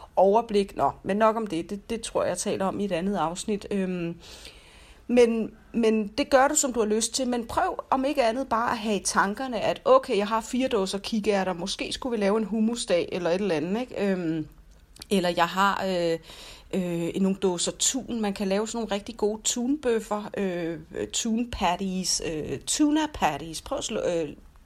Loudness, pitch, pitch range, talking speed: -26 LUFS, 210 Hz, 185-235 Hz, 200 wpm